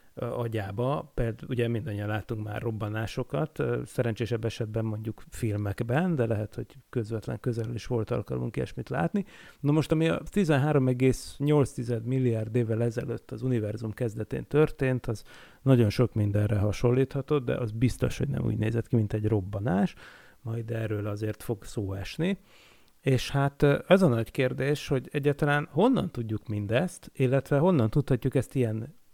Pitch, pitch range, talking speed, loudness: 120 Hz, 110-140 Hz, 145 wpm, -28 LUFS